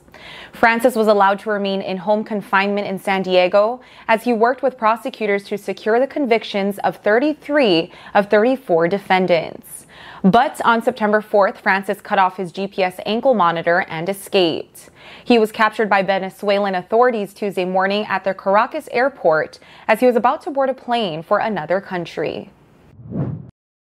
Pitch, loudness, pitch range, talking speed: 205 Hz, -18 LUFS, 190-235 Hz, 155 wpm